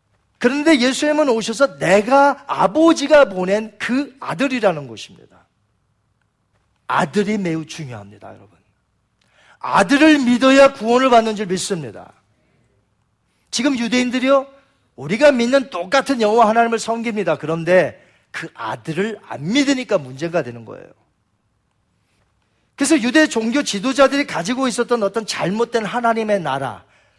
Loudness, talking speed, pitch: -17 LUFS, 290 characters per minute, 220 Hz